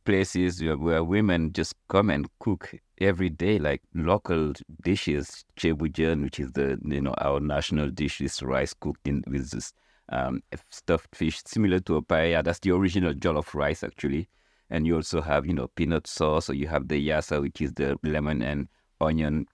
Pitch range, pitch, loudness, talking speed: 70-85 Hz, 80 Hz, -27 LUFS, 185 wpm